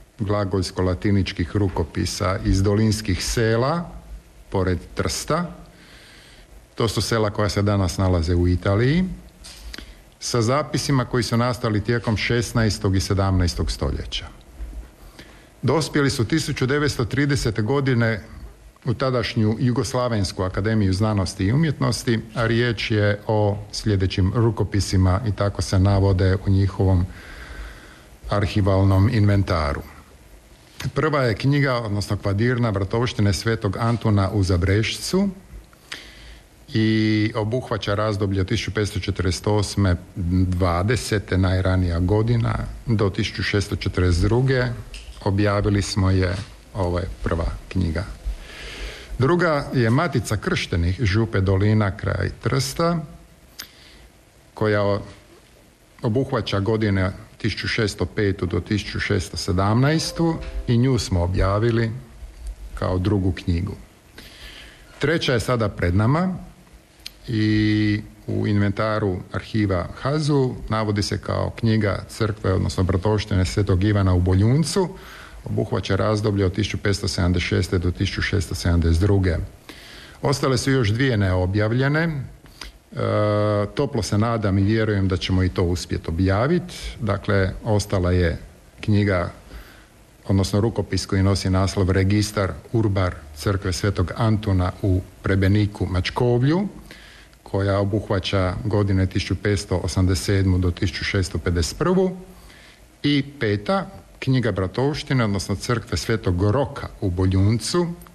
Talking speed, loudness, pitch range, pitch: 100 wpm, -22 LUFS, 95-115 Hz, 105 Hz